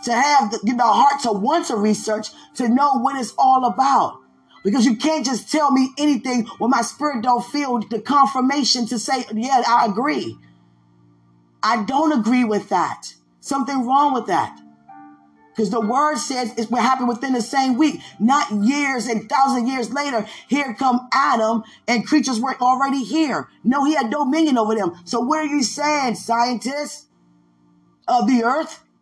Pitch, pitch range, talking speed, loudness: 245 Hz, 220-275 Hz, 175 wpm, -19 LUFS